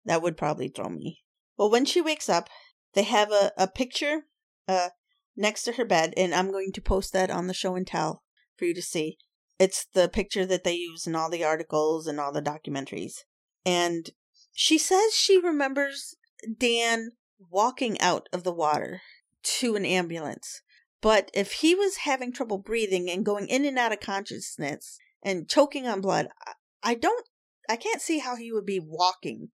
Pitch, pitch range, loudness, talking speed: 205 Hz, 180-270 Hz, -27 LUFS, 185 wpm